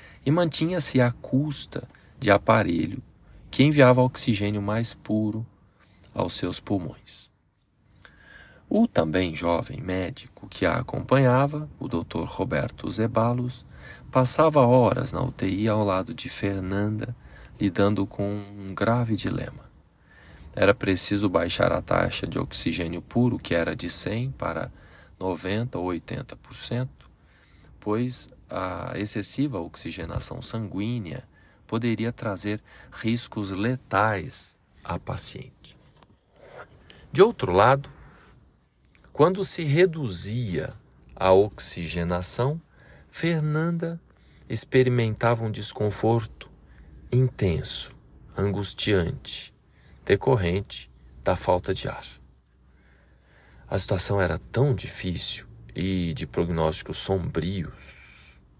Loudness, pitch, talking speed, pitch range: -24 LUFS, 105 Hz, 95 wpm, 90-125 Hz